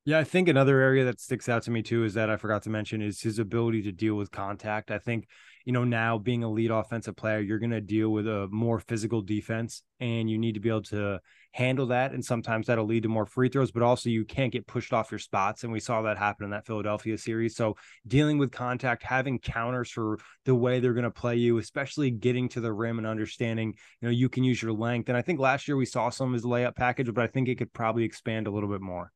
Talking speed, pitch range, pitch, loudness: 265 wpm, 110-125 Hz, 115 Hz, -28 LUFS